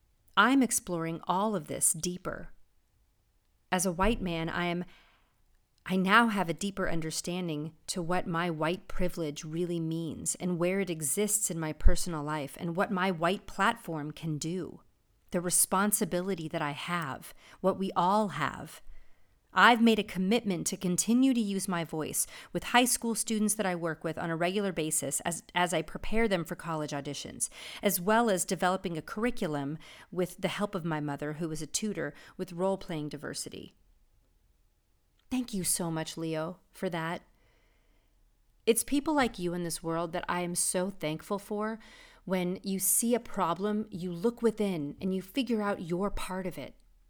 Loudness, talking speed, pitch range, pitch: -31 LUFS, 170 wpm, 165-200 Hz, 180 Hz